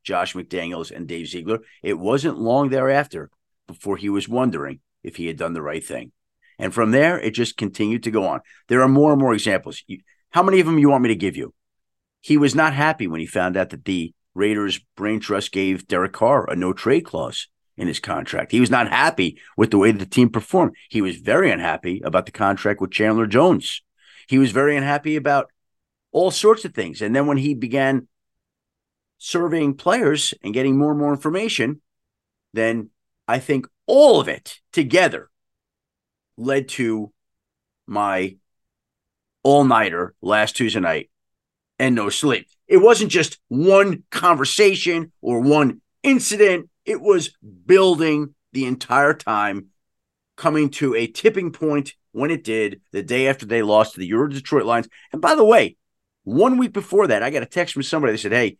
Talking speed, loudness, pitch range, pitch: 185 wpm, -19 LUFS, 105-150 Hz, 130 Hz